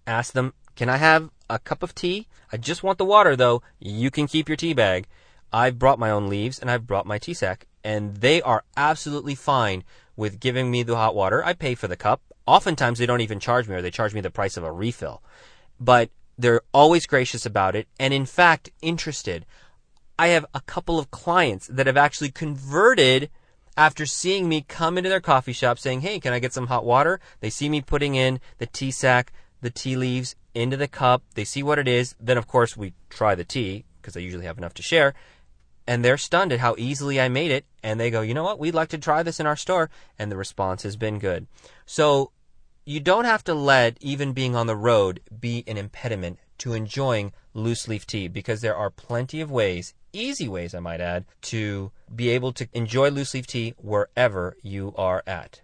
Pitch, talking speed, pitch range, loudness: 125 Hz, 220 wpm, 110-145 Hz, -23 LUFS